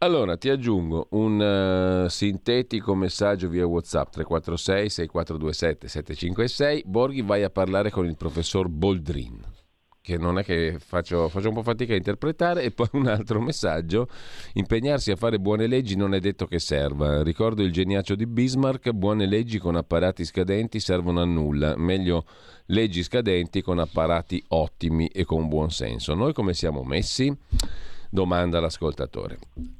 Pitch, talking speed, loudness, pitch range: 95 Hz, 145 wpm, -25 LUFS, 85-110 Hz